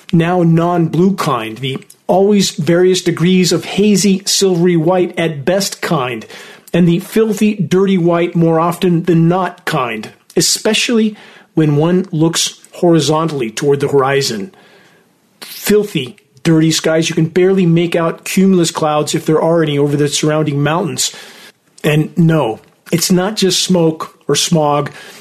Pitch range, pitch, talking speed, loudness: 160-185 Hz, 170 Hz, 140 wpm, -13 LUFS